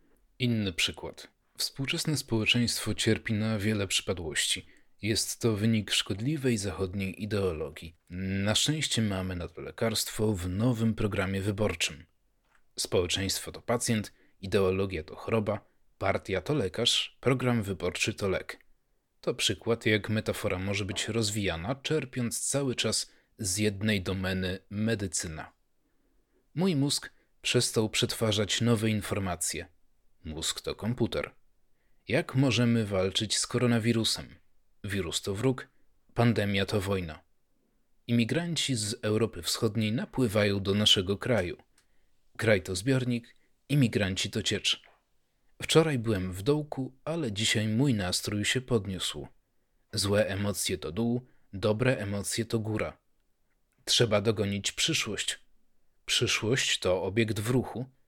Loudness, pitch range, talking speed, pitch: -29 LUFS, 95-120 Hz, 115 wpm, 110 Hz